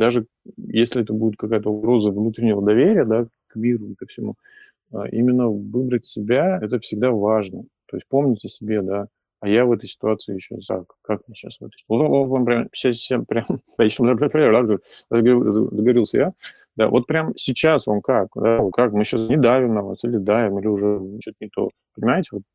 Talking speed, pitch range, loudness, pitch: 165 wpm, 105-125 Hz, -20 LUFS, 115 Hz